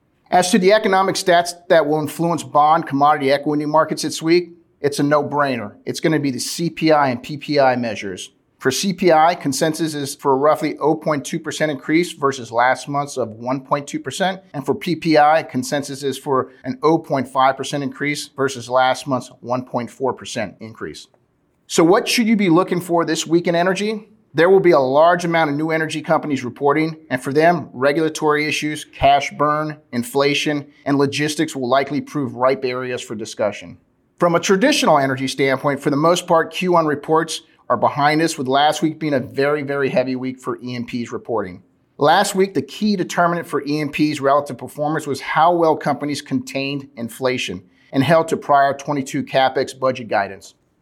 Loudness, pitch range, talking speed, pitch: -18 LUFS, 135-165 Hz, 170 wpm, 145 Hz